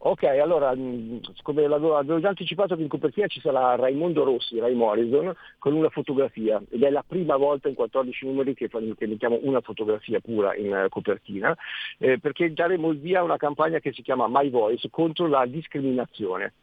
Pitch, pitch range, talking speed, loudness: 140 Hz, 125-160 Hz, 175 wpm, -25 LUFS